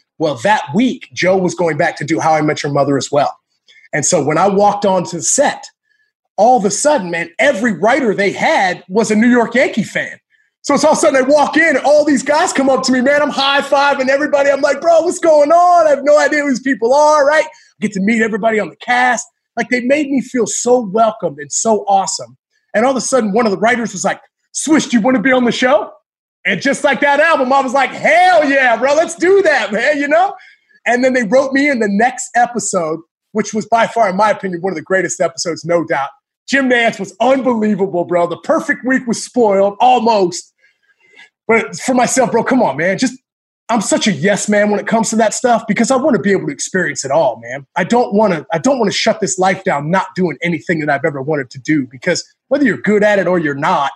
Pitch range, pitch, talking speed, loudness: 195-285 Hz, 240 Hz, 250 wpm, -13 LUFS